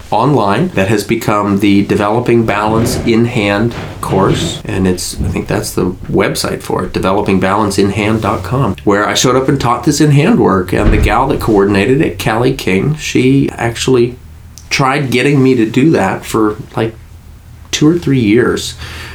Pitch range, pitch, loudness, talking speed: 100-125 Hz, 105 Hz, -12 LUFS, 165 wpm